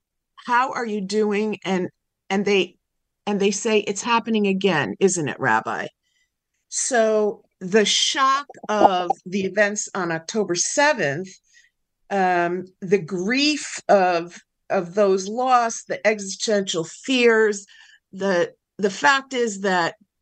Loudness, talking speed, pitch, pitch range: -21 LUFS, 120 wpm, 205 Hz, 190-230 Hz